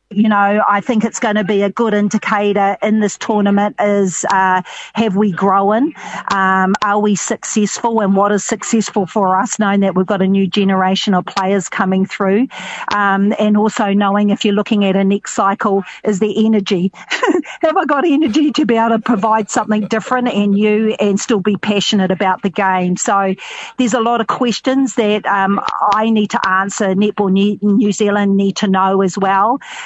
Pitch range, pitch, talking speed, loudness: 195-220 Hz, 205 Hz, 190 wpm, -14 LUFS